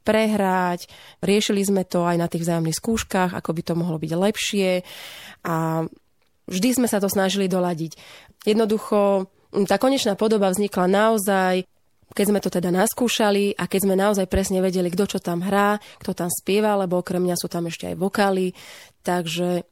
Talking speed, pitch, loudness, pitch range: 165 wpm, 190 Hz, -22 LUFS, 180-205 Hz